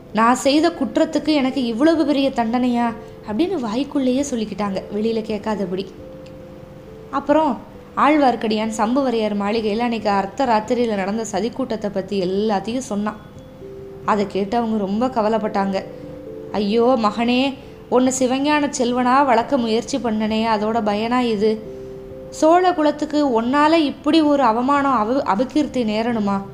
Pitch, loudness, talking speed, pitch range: 235 Hz, -19 LUFS, 115 wpm, 210-270 Hz